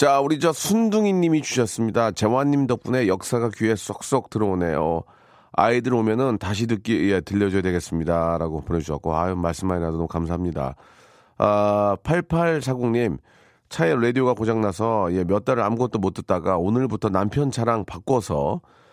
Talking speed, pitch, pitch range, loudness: 350 characters per minute, 110 Hz, 95-125 Hz, -22 LUFS